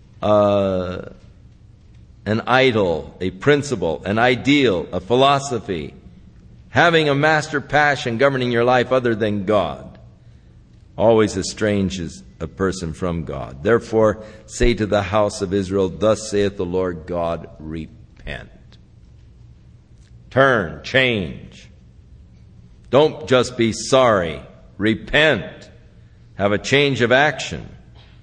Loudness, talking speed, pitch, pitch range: -18 LUFS, 105 wpm, 110 Hz, 95-125 Hz